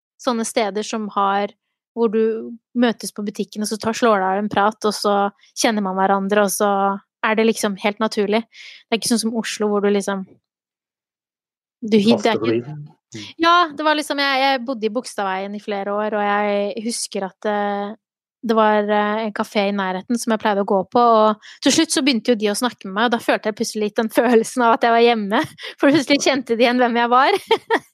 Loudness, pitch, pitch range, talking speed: -19 LUFS, 220 Hz, 205-240 Hz, 215 wpm